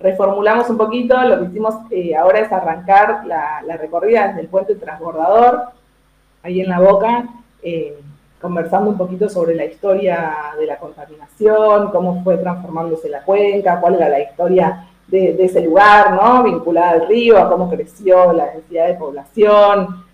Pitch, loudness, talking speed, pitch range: 185 Hz, -14 LUFS, 165 wpm, 165-210 Hz